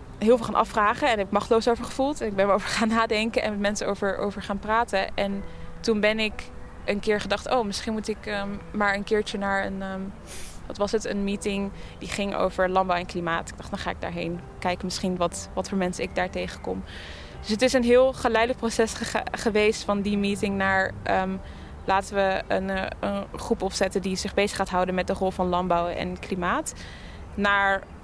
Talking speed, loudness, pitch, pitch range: 215 wpm, -26 LUFS, 200 Hz, 185-215 Hz